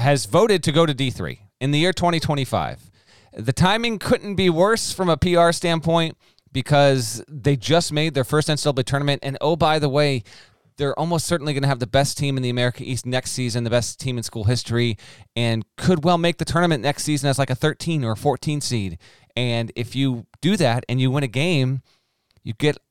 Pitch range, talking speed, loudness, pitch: 125-160 Hz, 210 wpm, -21 LUFS, 140 Hz